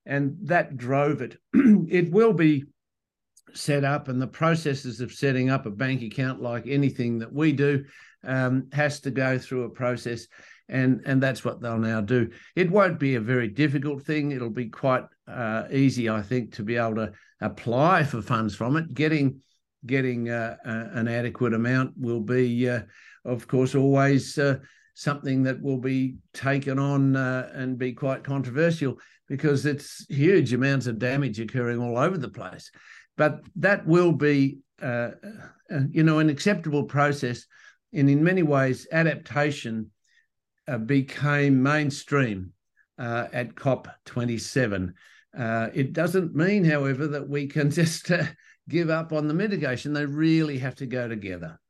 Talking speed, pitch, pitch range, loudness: 160 wpm, 135 Hz, 120-150 Hz, -25 LUFS